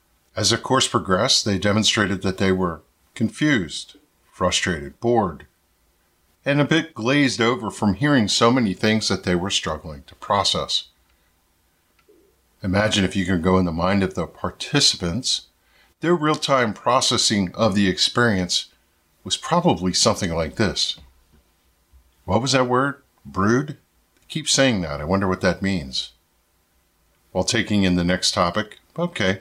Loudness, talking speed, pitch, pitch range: -20 LUFS, 145 wpm, 95 Hz, 85-115 Hz